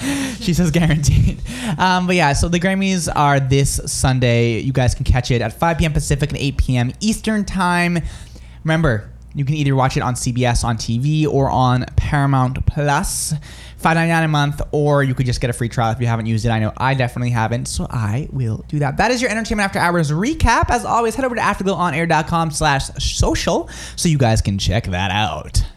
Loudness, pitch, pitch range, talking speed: -18 LUFS, 140 Hz, 120-170 Hz, 205 wpm